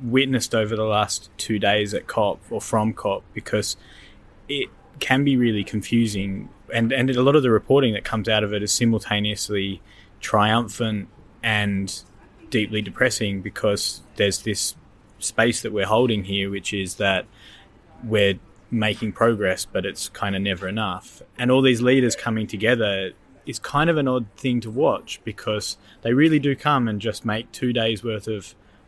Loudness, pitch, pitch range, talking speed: -22 LUFS, 110 Hz, 100-120 Hz, 170 wpm